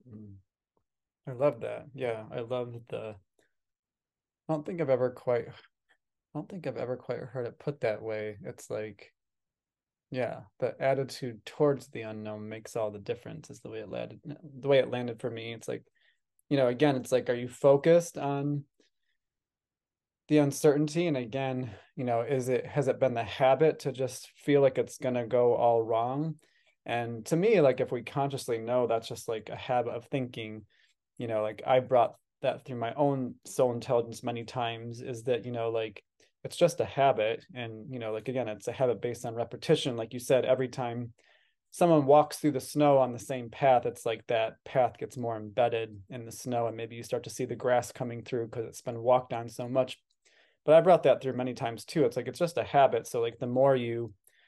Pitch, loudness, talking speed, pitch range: 125 Hz, -30 LUFS, 205 wpm, 115-135 Hz